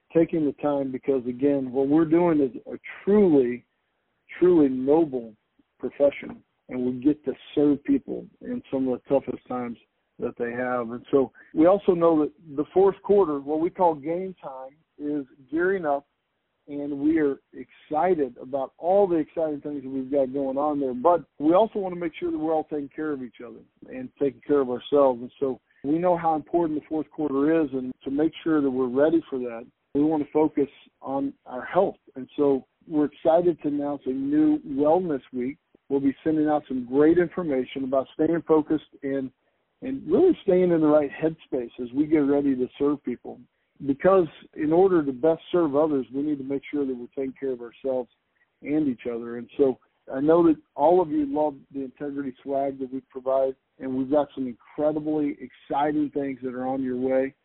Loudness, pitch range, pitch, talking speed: -25 LUFS, 135-160 Hz, 145 Hz, 200 wpm